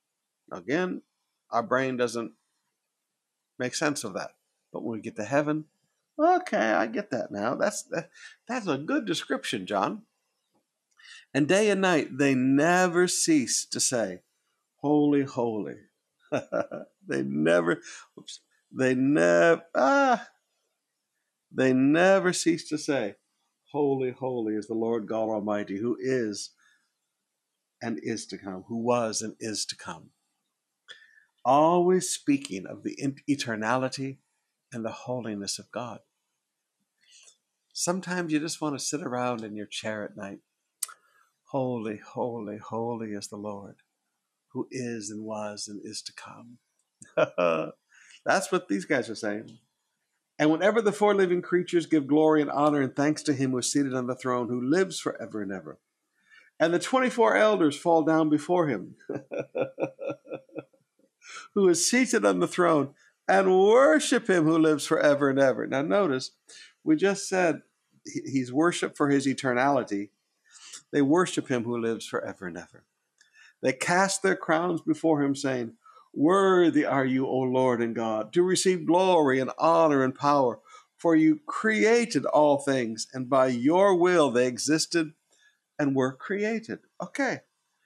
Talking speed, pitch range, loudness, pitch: 145 wpm, 120-180 Hz, -26 LUFS, 145 Hz